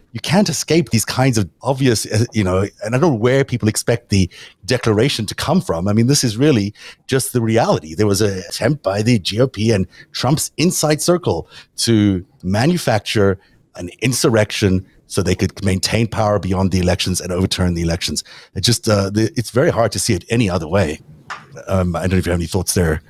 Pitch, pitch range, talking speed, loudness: 110 Hz, 95-125 Hz, 200 wpm, -17 LUFS